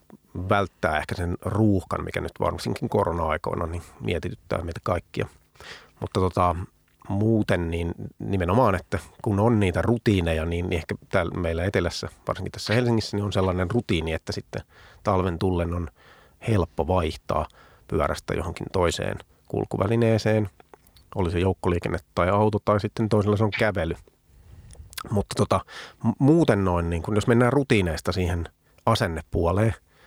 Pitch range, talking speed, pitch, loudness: 85-110 Hz, 135 wpm, 95 Hz, -25 LUFS